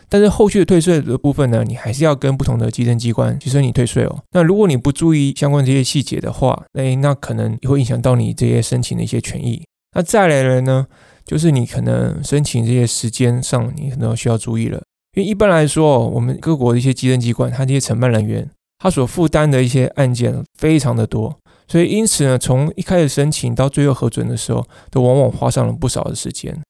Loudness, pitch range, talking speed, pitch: -16 LUFS, 120-155 Hz, 350 characters per minute, 135 Hz